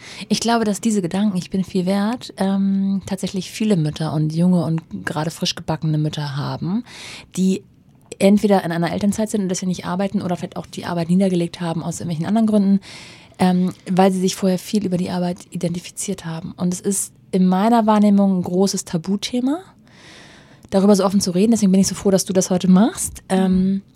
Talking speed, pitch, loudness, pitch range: 195 wpm, 190 Hz, -19 LUFS, 180-200 Hz